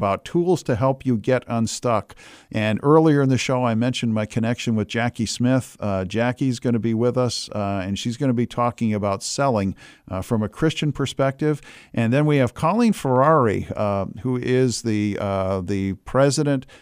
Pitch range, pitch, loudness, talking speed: 105-135 Hz, 120 Hz, -21 LUFS, 180 wpm